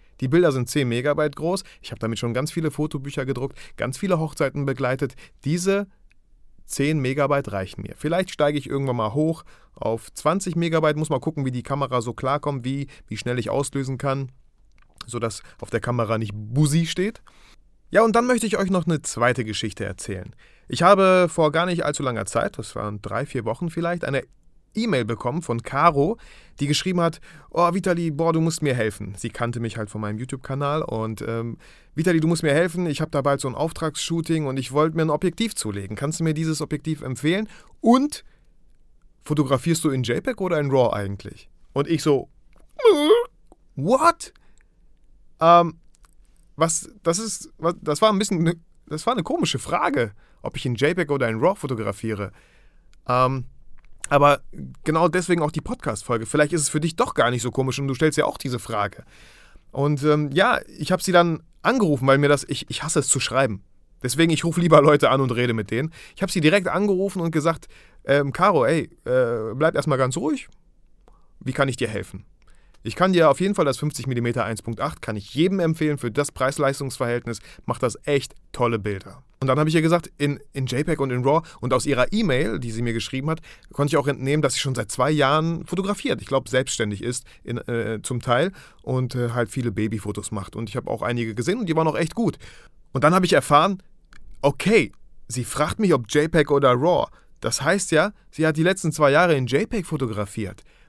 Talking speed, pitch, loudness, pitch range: 200 wpm, 145 Hz, -22 LUFS, 120-165 Hz